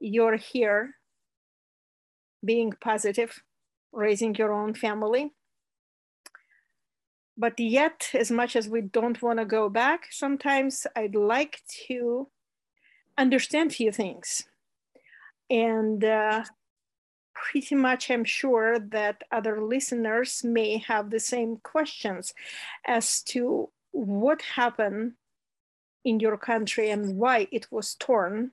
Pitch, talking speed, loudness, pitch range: 230 Hz, 110 wpm, -27 LUFS, 220-255 Hz